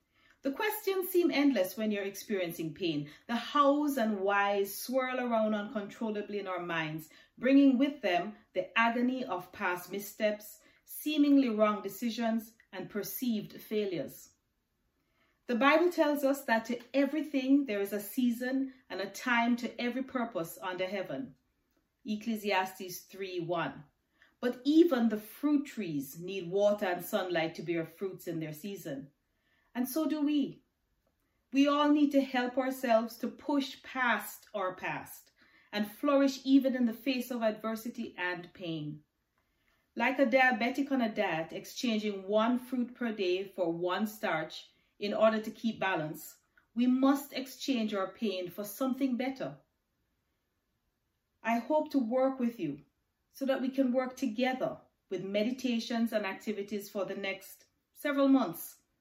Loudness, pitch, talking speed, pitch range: -32 LUFS, 230 Hz, 145 wpm, 195-265 Hz